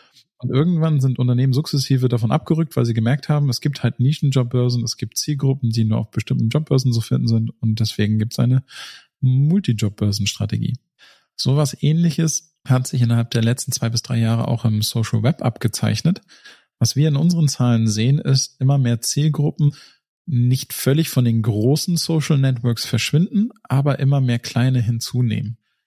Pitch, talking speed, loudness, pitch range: 130 Hz, 165 wpm, -19 LUFS, 115-145 Hz